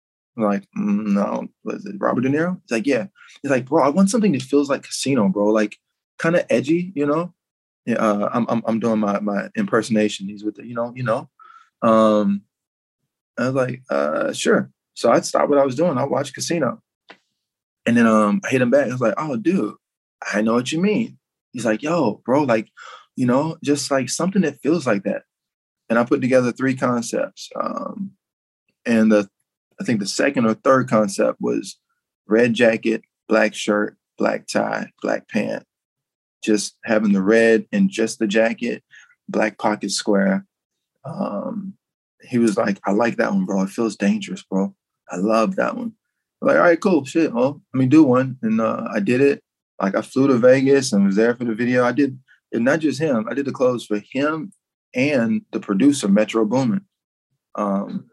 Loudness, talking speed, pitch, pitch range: -20 LUFS, 195 wpm, 120 Hz, 105-145 Hz